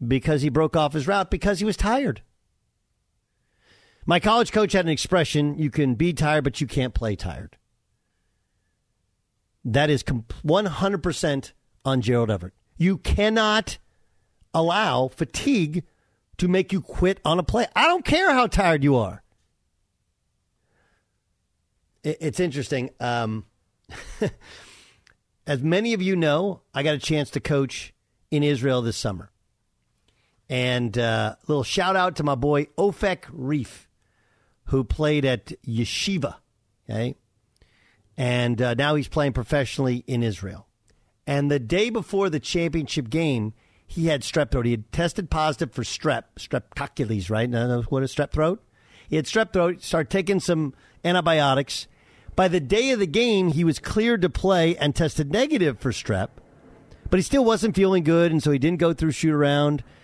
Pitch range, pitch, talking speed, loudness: 115-170 Hz, 145 Hz, 155 wpm, -23 LUFS